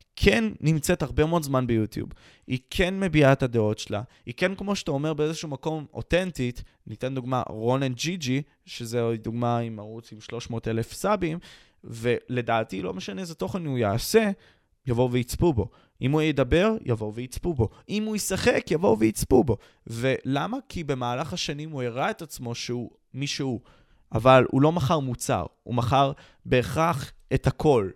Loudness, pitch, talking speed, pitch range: -26 LUFS, 130 Hz, 165 wpm, 115-155 Hz